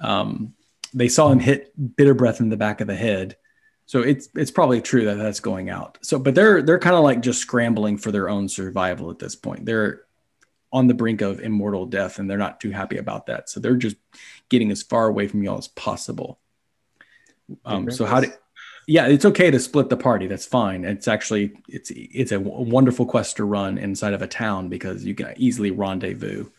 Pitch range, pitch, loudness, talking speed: 100-125 Hz, 110 Hz, -21 LUFS, 215 wpm